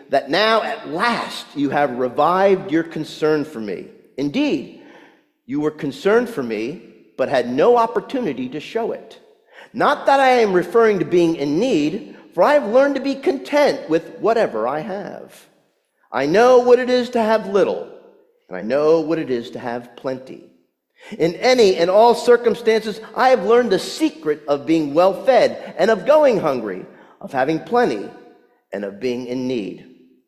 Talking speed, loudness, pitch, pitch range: 170 wpm, -18 LUFS, 215 Hz, 155-255 Hz